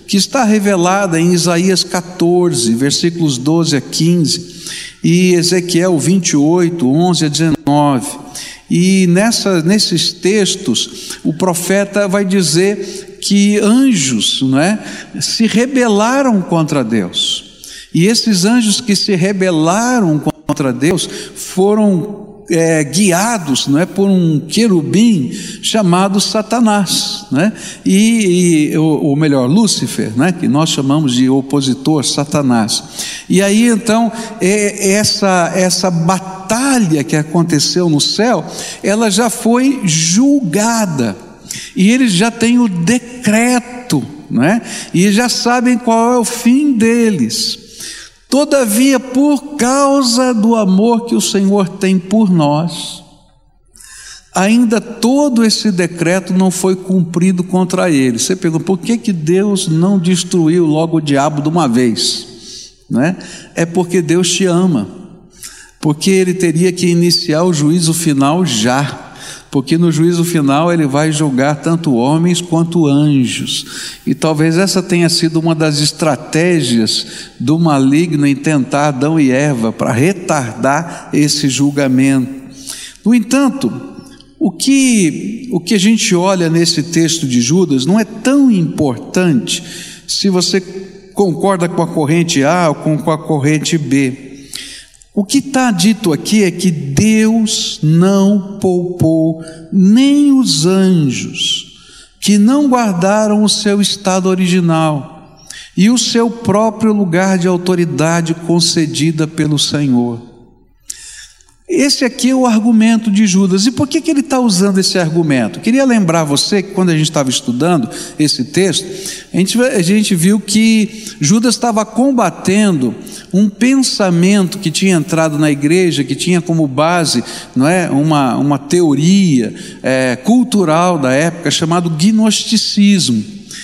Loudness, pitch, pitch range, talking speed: -12 LUFS, 185 Hz, 155-210 Hz, 130 wpm